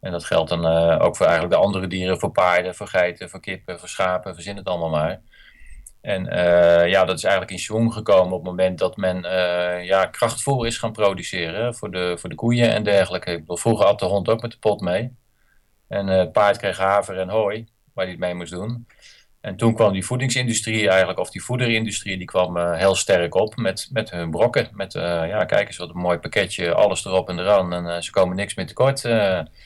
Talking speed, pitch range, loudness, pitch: 230 wpm, 90-110 Hz, -21 LUFS, 95 Hz